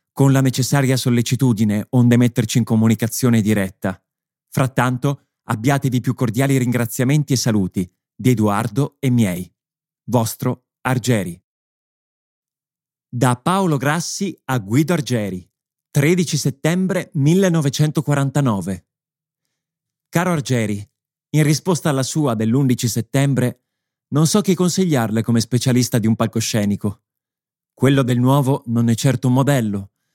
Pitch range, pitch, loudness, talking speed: 115-150 Hz, 130 Hz, -18 LUFS, 110 wpm